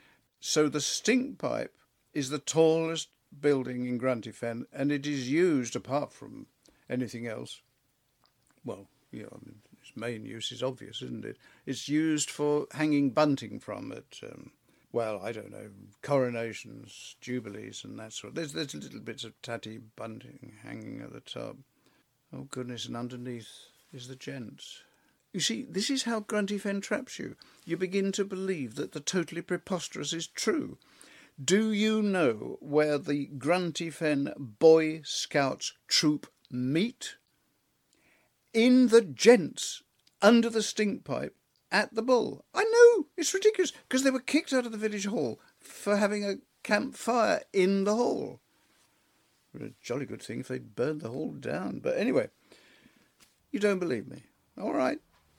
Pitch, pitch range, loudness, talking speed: 160 Hz, 130-215 Hz, -29 LUFS, 155 wpm